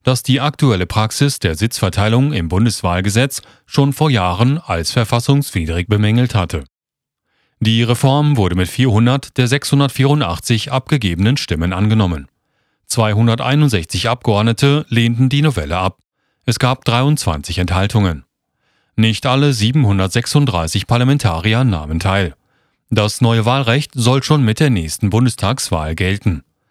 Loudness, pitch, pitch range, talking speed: -15 LUFS, 115 Hz, 100-135 Hz, 115 wpm